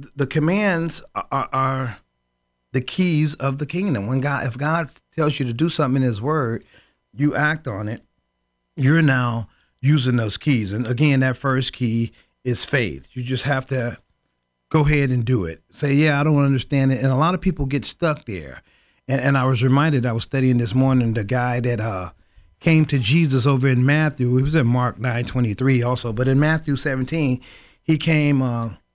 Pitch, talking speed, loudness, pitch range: 130 Hz, 200 wpm, -20 LUFS, 120-145 Hz